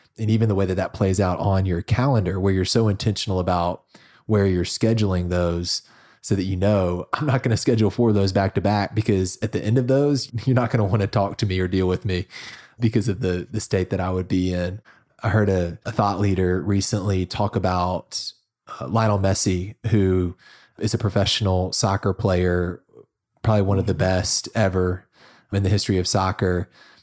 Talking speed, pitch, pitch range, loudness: 205 wpm, 100 Hz, 90-110 Hz, -22 LUFS